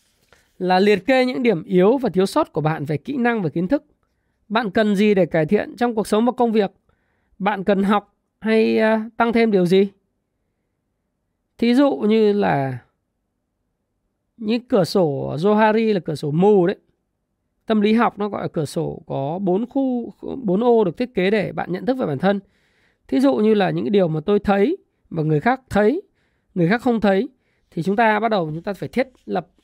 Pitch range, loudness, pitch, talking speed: 180-230 Hz, -19 LUFS, 205 Hz, 200 wpm